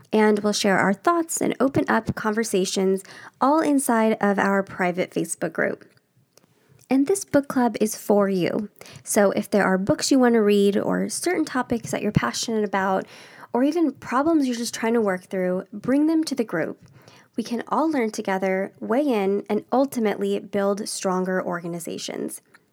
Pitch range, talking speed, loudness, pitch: 195-245 Hz, 170 wpm, -23 LUFS, 210 Hz